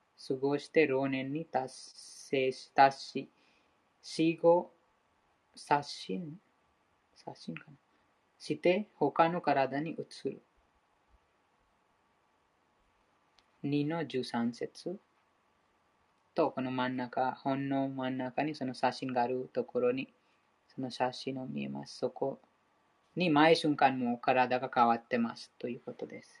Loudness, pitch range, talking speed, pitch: -32 LUFS, 130-160 Hz, 200 characters per minute, 135 Hz